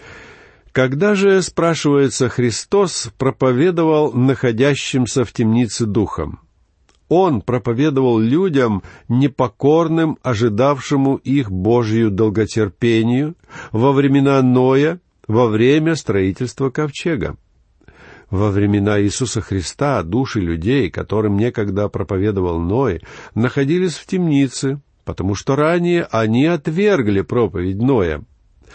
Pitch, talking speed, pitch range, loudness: 125 Hz, 90 wpm, 105-140 Hz, -17 LUFS